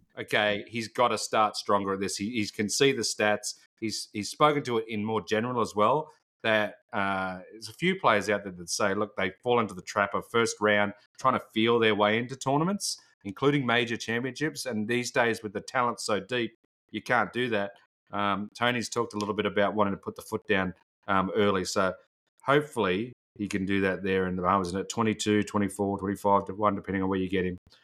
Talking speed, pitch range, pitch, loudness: 220 wpm, 100-115 Hz, 105 Hz, -28 LUFS